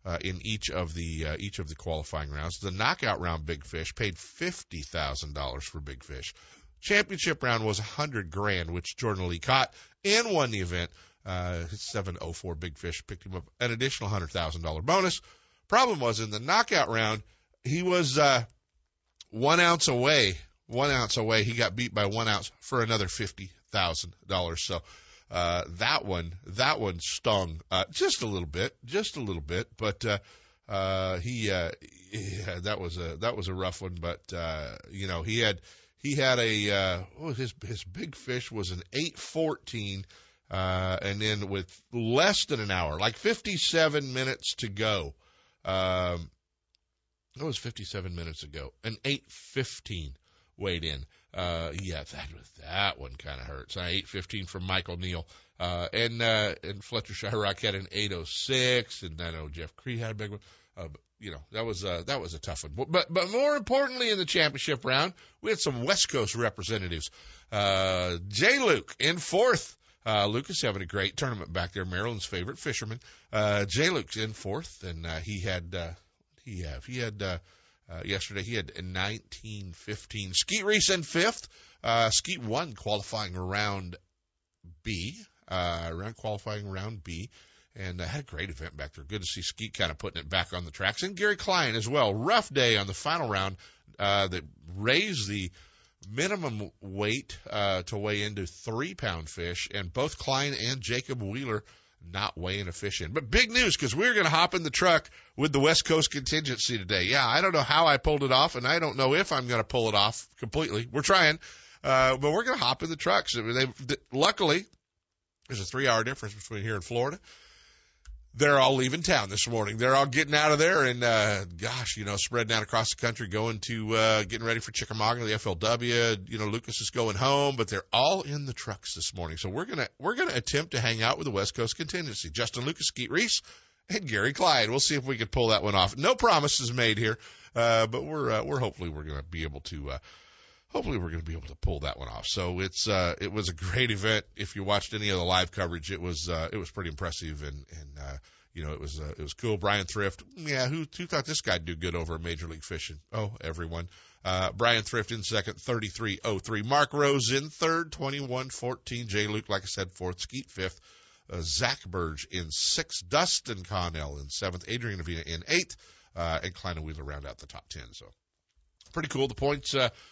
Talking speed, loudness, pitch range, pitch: 205 wpm, -29 LUFS, 90-120 Hz, 100 Hz